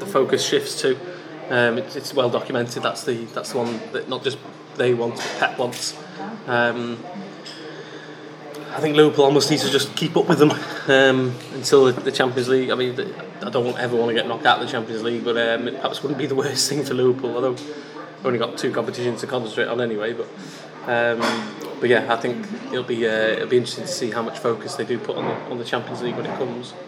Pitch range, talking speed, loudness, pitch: 120-145 Hz, 235 wpm, -21 LUFS, 130 Hz